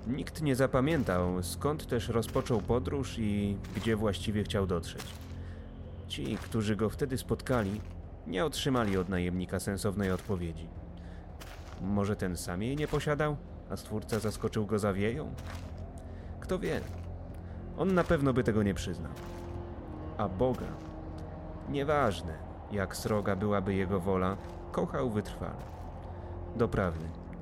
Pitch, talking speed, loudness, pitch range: 95 Hz, 120 wpm, -33 LUFS, 85-110 Hz